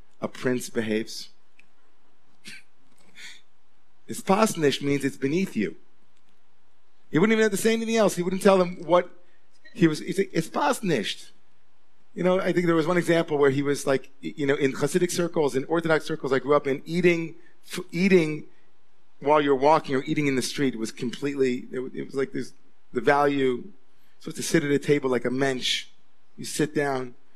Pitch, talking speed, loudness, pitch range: 150 Hz, 180 wpm, -24 LUFS, 135-180 Hz